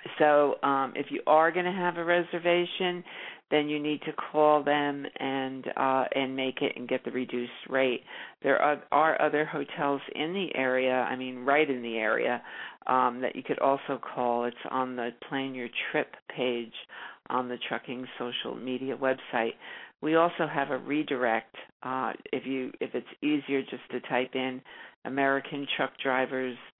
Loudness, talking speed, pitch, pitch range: -29 LUFS, 170 wpm, 135 Hz, 125-150 Hz